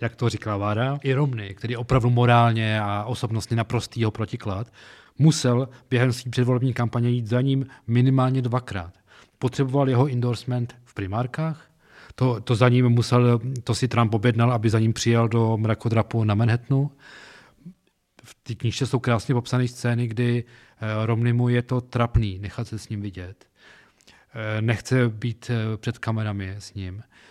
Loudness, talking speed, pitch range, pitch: -23 LUFS, 155 wpm, 110-125 Hz, 120 Hz